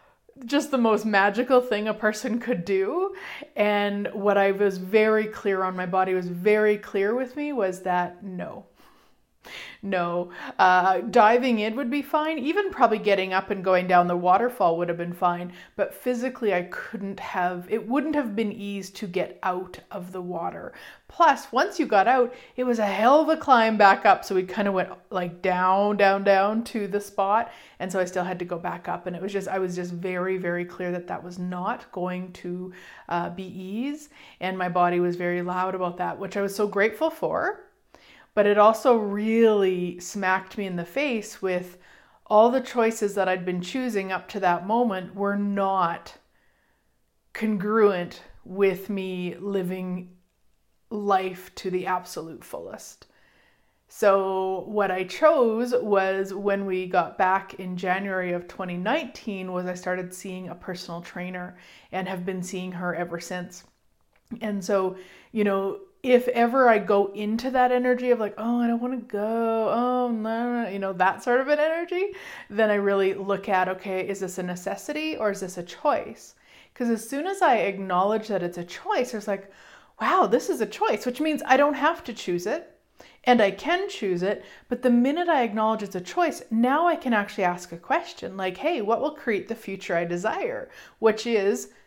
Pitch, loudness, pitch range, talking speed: 200 Hz, -25 LUFS, 185-235 Hz, 190 wpm